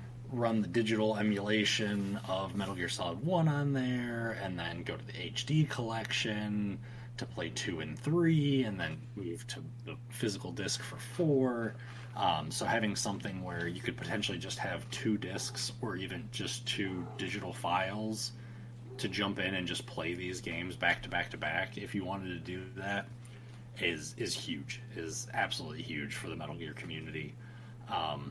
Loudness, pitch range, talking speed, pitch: -35 LUFS, 105-125 Hz, 170 wpm, 120 Hz